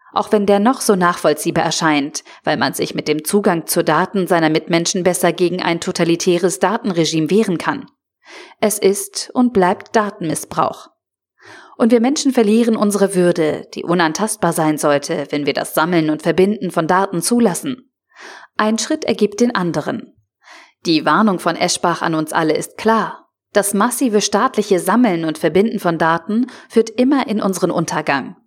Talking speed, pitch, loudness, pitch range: 160 wpm, 185 Hz, -16 LUFS, 165-215 Hz